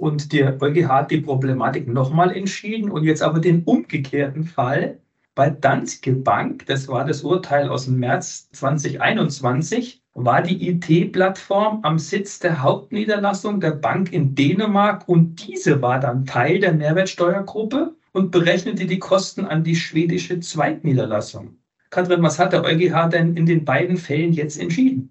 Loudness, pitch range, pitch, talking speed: -19 LUFS, 140-185 Hz, 165 Hz, 150 wpm